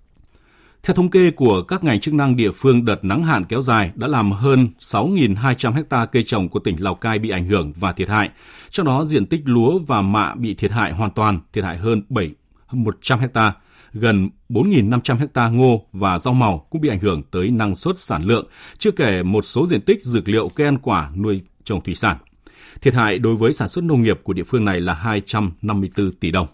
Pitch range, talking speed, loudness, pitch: 100-130 Hz, 215 wpm, -18 LUFS, 110 Hz